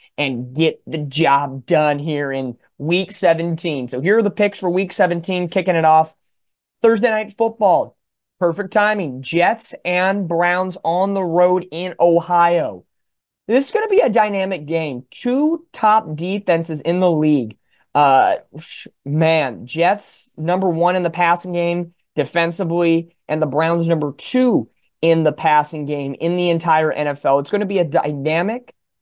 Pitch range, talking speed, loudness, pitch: 155-190 Hz, 155 wpm, -18 LUFS, 170 Hz